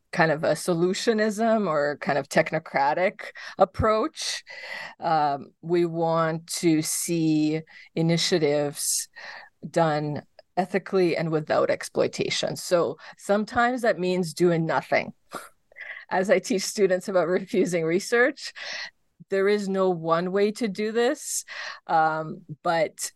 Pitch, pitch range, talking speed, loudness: 180 Hz, 160-205 Hz, 110 wpm, -25 LUFS